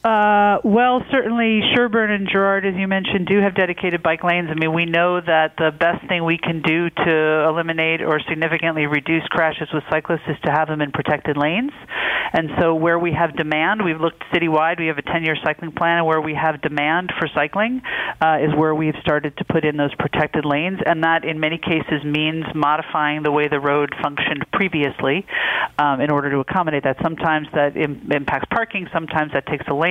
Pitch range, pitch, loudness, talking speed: 155-175 Hz, 160 Hz, -19 LUFS, 205 wpm